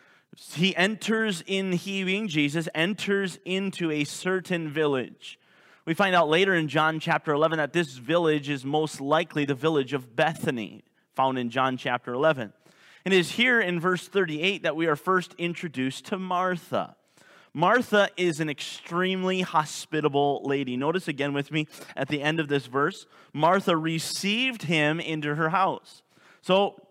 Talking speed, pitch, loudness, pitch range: 155 wpm, 165 Hz, -26 LUFS, 150-185 Hz